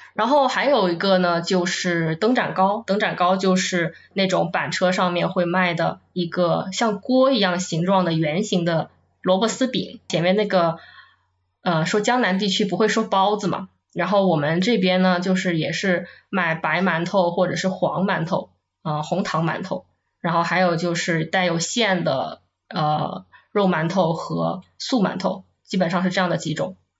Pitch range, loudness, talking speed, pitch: 170-195 Hz, -21 LUFS, 250 characters per minute, 185 Hz